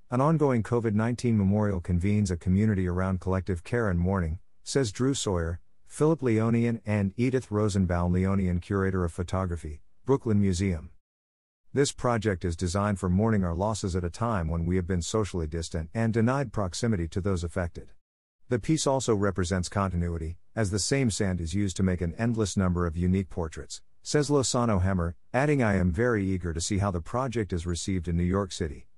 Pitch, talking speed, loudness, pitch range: 95 Hz, 180 wpm, -28 LUFS, 90-115 Hz